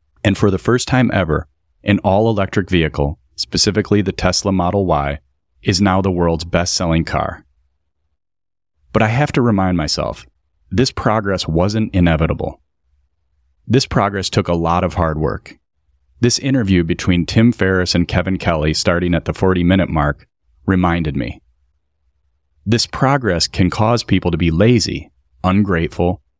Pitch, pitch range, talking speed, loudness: 90 Hz, 75-100 Hz, 150 wpm, -16 LUFS